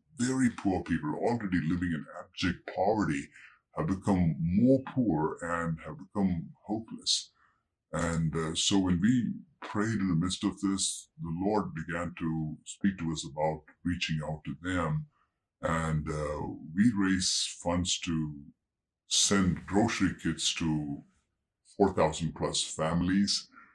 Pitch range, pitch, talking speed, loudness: 80-100 Hz, 85 Hz, 130 wpm, -31 LUFS